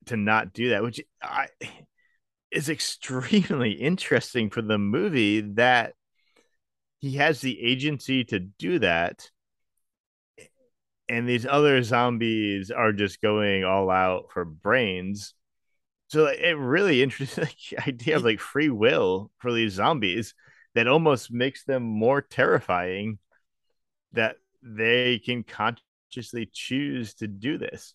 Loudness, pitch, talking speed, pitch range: -25 LUFS, 120 Hz, 120 wpm, 105-135 Hz